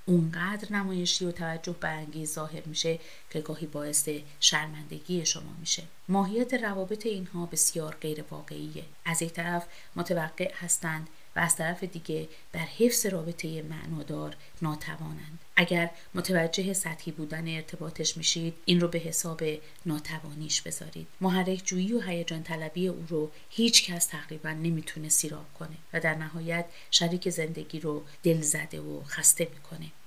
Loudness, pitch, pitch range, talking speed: -29 LUFS, 165 Hz, 155-175 Hz, 140 wpm